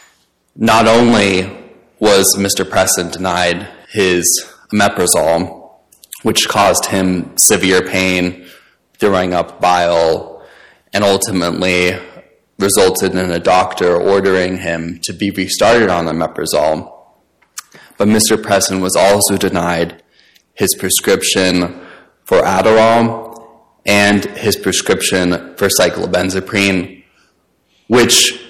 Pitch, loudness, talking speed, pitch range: 95 Hz, -13 LUFS, 95 wpm, 90-100 Hz